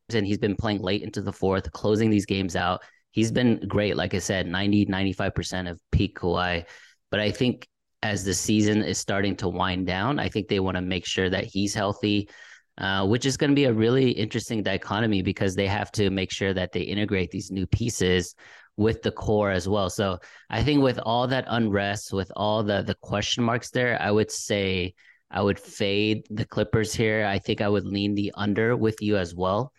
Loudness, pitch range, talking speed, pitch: -25 LUFS, 95-110 Hz, 210 wpm, 100 Hz